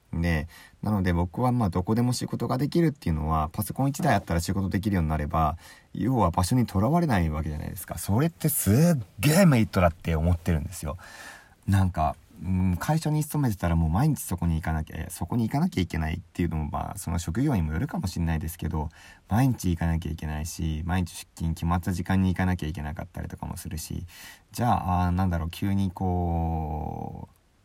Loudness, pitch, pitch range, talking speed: -27 LUFS, 90 Hz, 80-105 Hz, 445 characters per minute